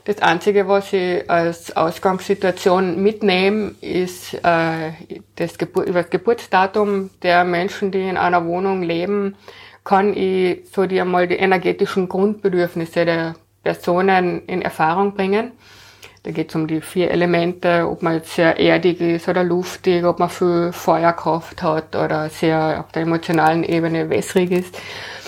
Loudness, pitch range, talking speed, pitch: -18 LUFS, 170-190 Hz, 145 wpm, 180 Hz